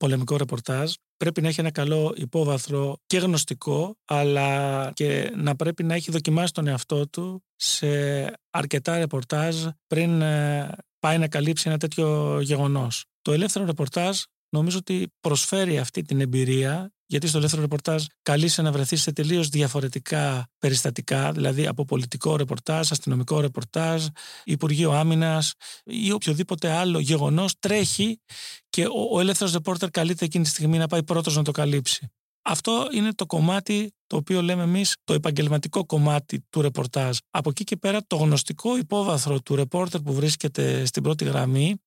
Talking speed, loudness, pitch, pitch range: 150 wpm, -24 LUFS, 155 Hz, 145-175 Hz